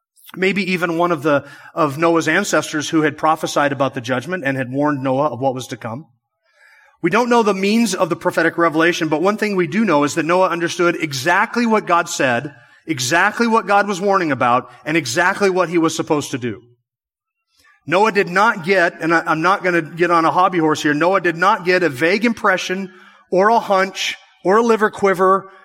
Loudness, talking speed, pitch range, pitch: -17 LUFS, 210 wpm, 155-195 Hz, 175 Hz